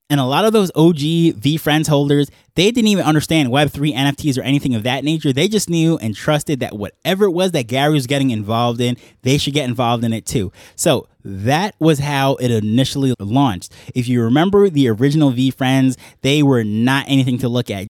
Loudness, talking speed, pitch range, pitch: -16 LUFS, 205 wpm, 125-150 Hz, 140 Hz